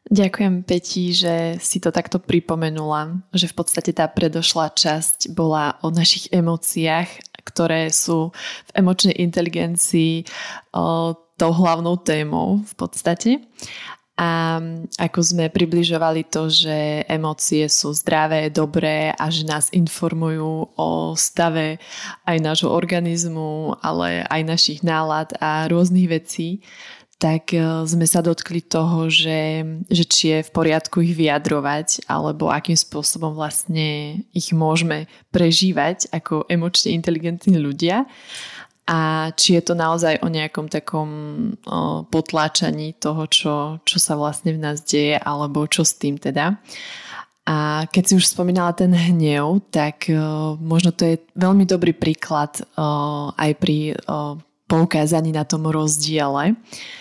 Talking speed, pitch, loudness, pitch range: 125 wpm, 165 Hz, -19 LUFS, 155-175 Hz